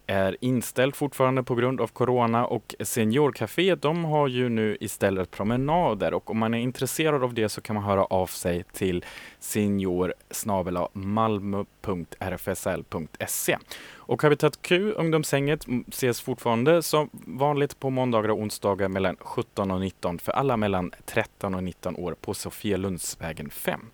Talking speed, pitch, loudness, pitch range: 145 wpm, 115 Hz, -26 LUFS, 100-135 Hz